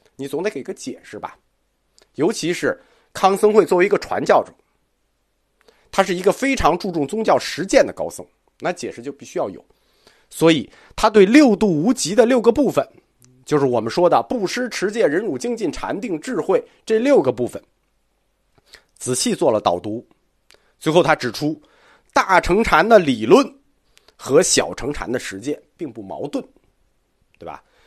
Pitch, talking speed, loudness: 185 Hz, 235 characters per minute, -18 LUFS